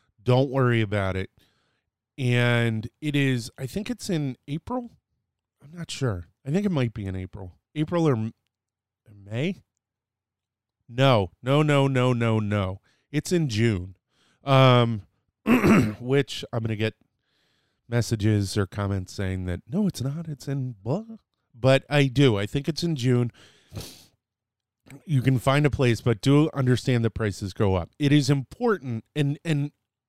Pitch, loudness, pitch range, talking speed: 125 Hz, -24 LUFS, 110-140 Hz, 150 wpm